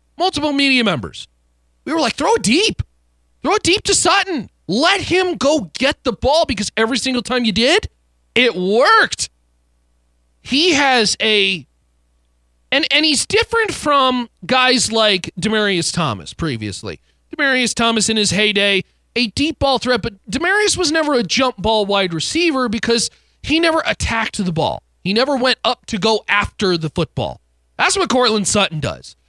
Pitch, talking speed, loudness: 225 Hz, 160 wpm, -16 LUFS